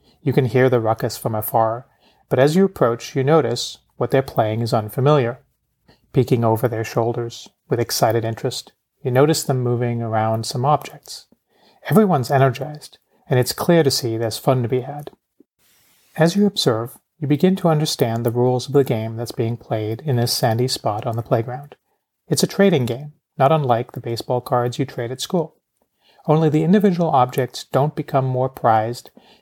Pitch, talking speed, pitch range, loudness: 130 Hz, 175 wpm, 120-150 Hz, -19 LUFS